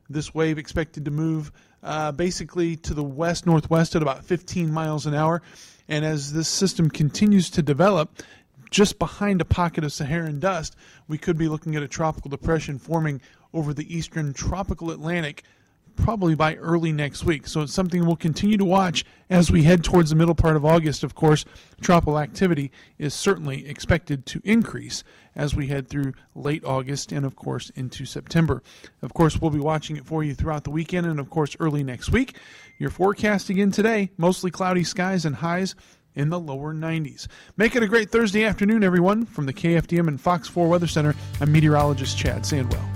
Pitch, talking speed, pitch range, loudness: 160 Hz, 190 wpm, 150-175 Hz, -23 LUFS